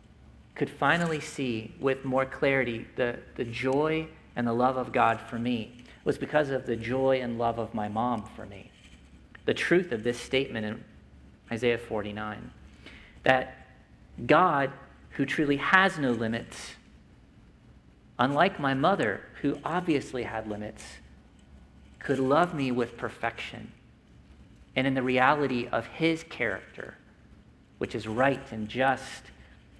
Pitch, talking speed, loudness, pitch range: 125 Hz, 135 wpm, -28 LUFS, 110-135 Hz